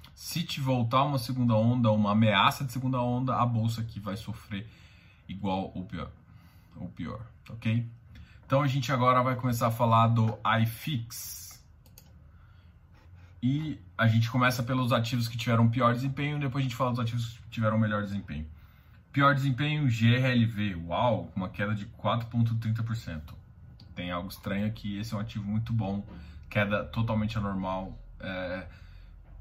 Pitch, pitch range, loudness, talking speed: 110 Hz, 95-120 Hz, -29 LUFS, 150 wpm